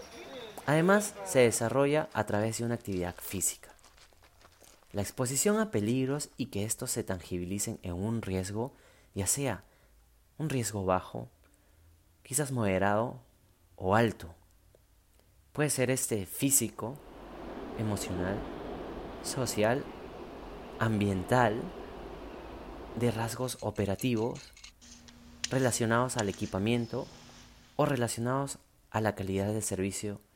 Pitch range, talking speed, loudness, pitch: 95-125 Hz, 100 wpm, -31 LUFS, 110 Hz